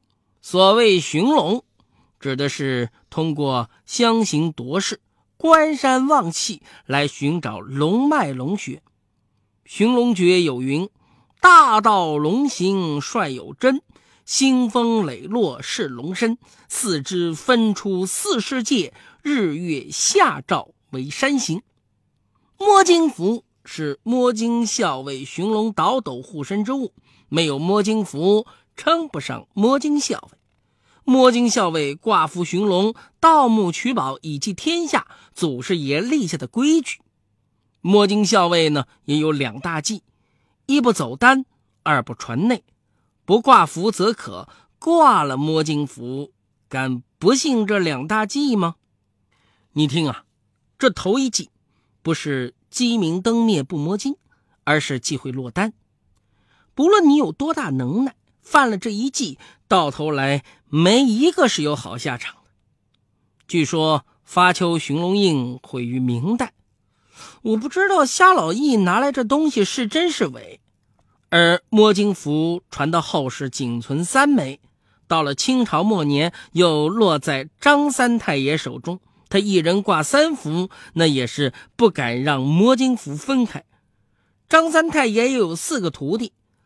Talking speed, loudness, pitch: 190 characters per minute, -19 LUFS, 180 Hz